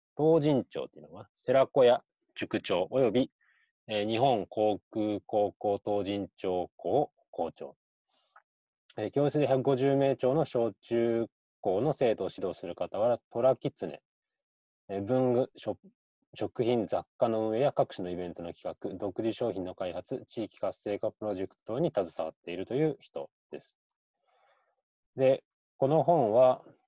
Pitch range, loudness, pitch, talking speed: 105-140 Hz, -30 LUFS, 115 Hz, 255 characters per minute